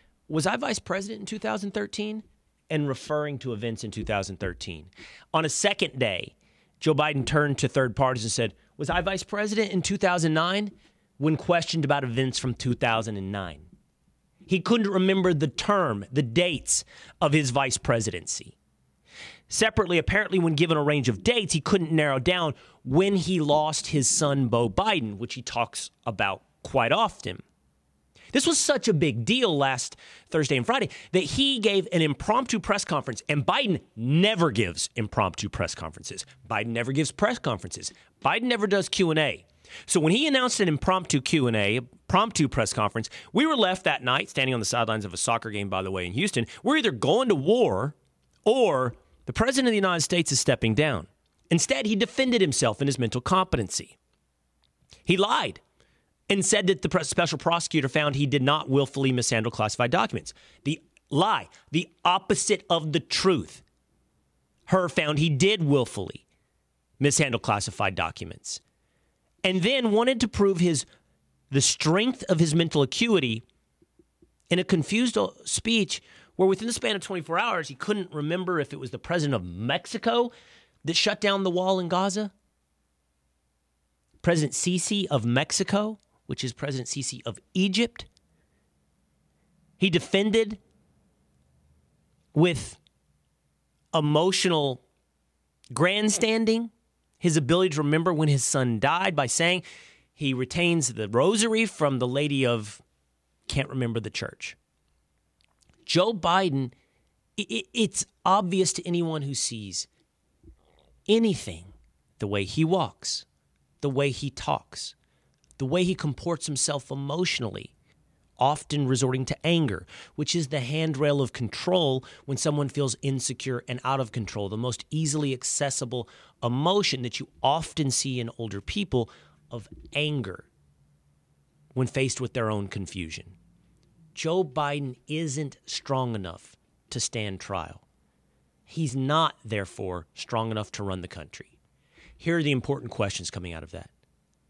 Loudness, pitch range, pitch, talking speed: -26 LUFS, 115-180 Hz, 145 Hz, 145 wpm